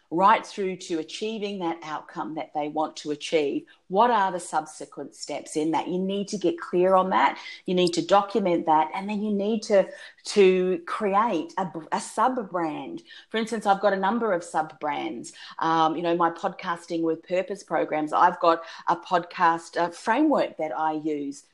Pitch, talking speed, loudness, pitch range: 180 Hz, 185 wpm, -25 LUFS, 160-200 Hz